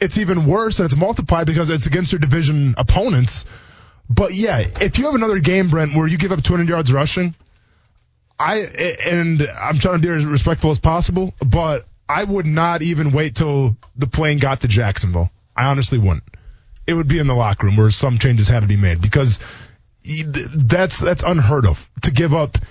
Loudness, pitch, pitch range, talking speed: -17 LUFS, 145 Hz, 115-170 Hz, 195 wpm